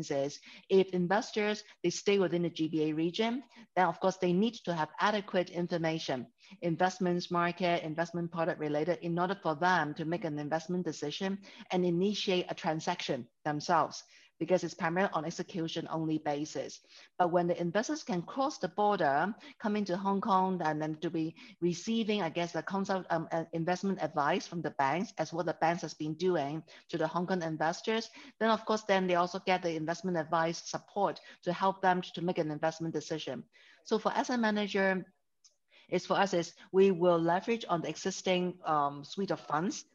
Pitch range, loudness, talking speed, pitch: 160-195 Hz, -33 LUFS, 185 wpm, 175 Hz